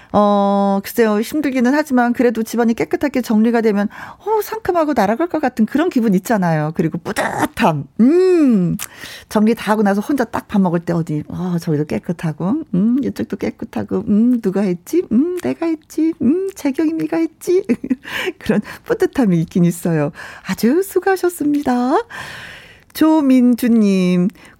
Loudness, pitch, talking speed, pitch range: -17 LUFS, 240 Hz, 310 characters per minute, 195-315 Hz